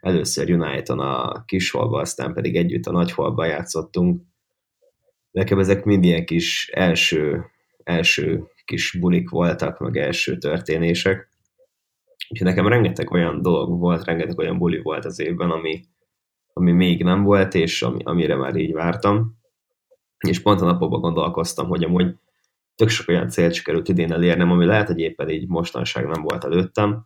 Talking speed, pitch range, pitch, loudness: 155 wpm, 85-100 Hz, 90 Hz, -20 LUFS